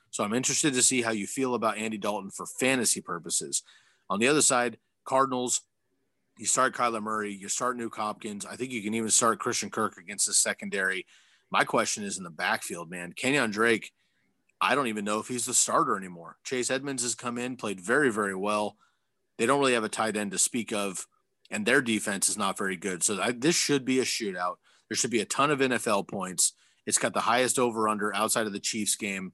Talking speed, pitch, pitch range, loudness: 220 wpm, 115 Hz, 105-125 Hz, -27 LUFS